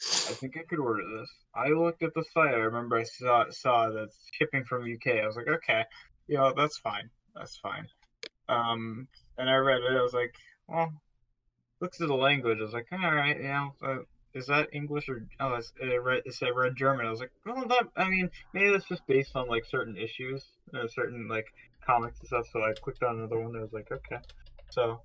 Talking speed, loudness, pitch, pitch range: 235 wpm, -30 LUFS, 130 Hz, 120-150 Hz